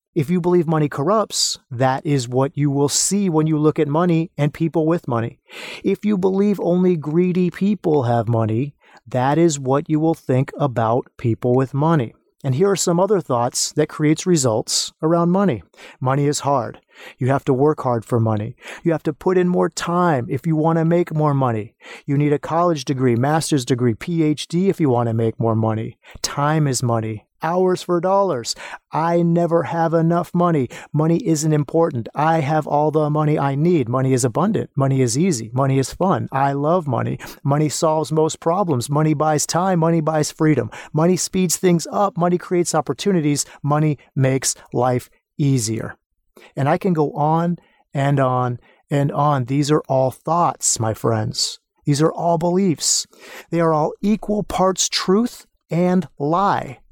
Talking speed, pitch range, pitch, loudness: 180 wpm, 135-170 Hz, 155 Hz, -19 LUFS